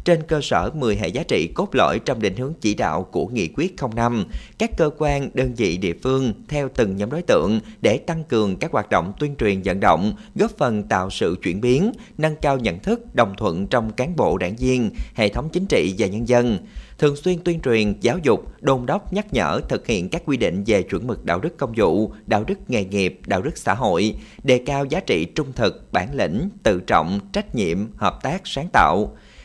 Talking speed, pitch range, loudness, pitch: 225 wpm, 115-180 Hz, -21 LUFS, 140 Hz